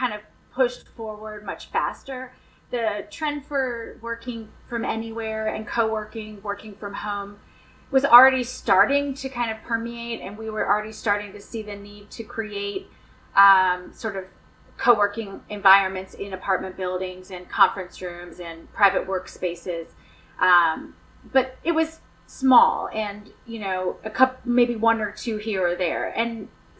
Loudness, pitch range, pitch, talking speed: -23 LUFS, 200-240 Hz, 215 Hz, 150 wpm